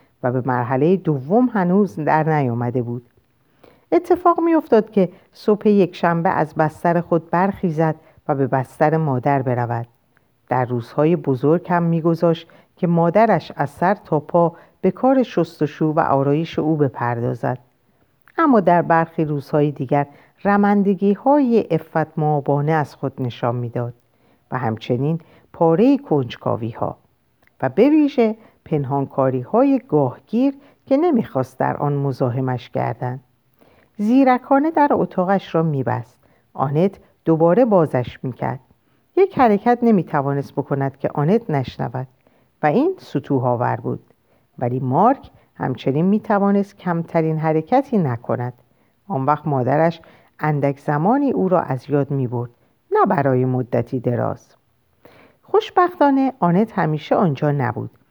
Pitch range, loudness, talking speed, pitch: 130-195 Hz, -19 LUFS, 120 wpm, 155 Hz